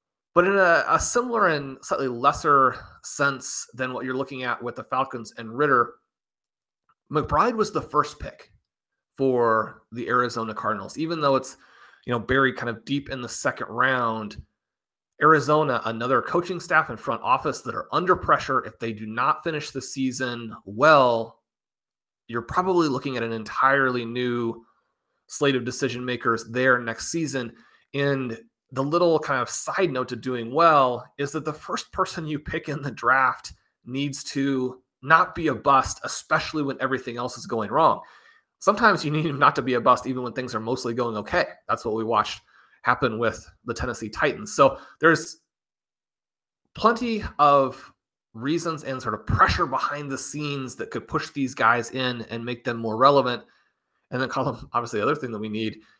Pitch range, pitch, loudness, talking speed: 120-150 Hz, 130 Hz, -24 LUFS, 180 wpm